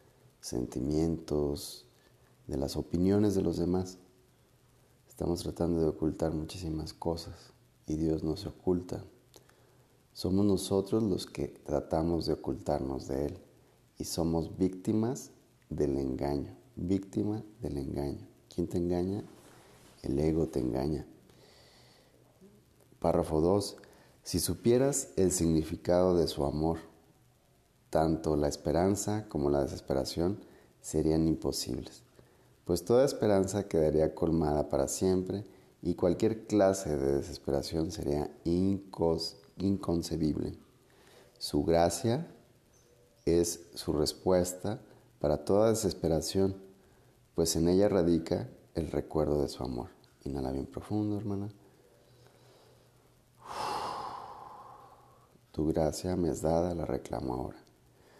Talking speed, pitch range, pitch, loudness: 105 wpm, 75-100 Hz, 85 Hz, -32 LUFS